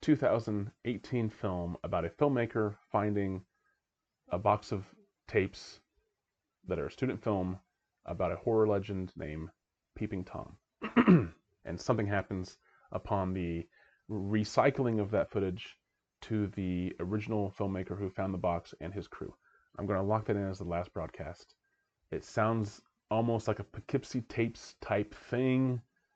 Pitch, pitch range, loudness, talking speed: 105 Hz, 95-115 Hz, -34 LUFS, 140 wpm